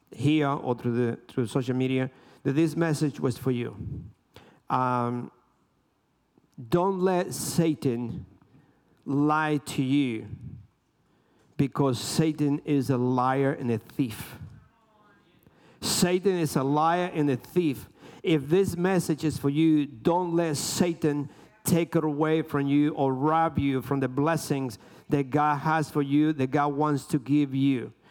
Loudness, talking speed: -26 LUFS, 140 wpm